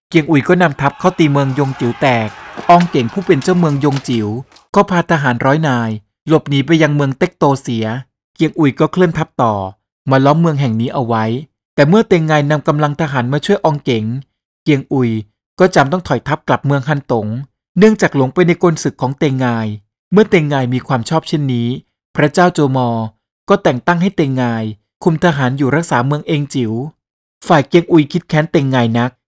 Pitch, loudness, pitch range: 140 Hz, -14 LUFS, 125-165 Hz